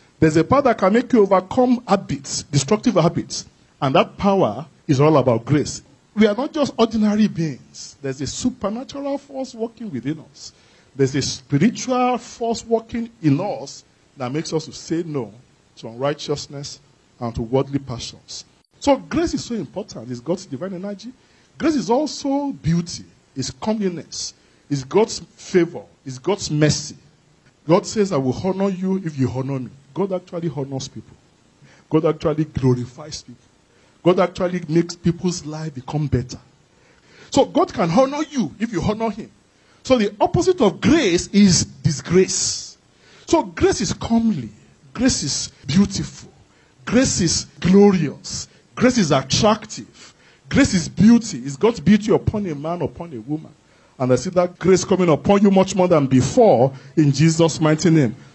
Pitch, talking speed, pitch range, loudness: 170 Hz, 155 wpm, 140-215 Hz, -19 LUFS